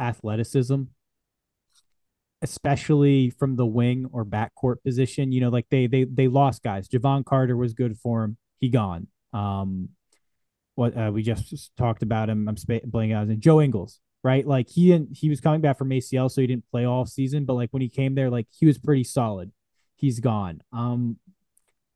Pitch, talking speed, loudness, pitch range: 125 Hz, 190 wpm, -24 LUFS, 115-135 Hz